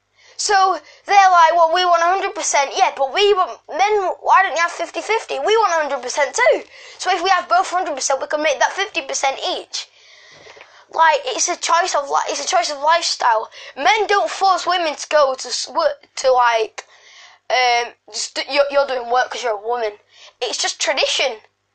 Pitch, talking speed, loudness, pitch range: 325 Hz, 180 wpm, -17 LUFS, 275-370 Hz